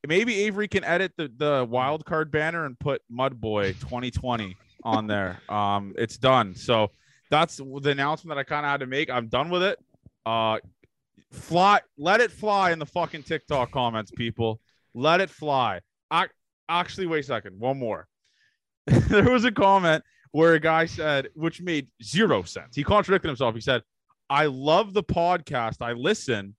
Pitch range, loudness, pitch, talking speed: 120-165 Hz, -25 LUFS, 145 Hz, 175 wpm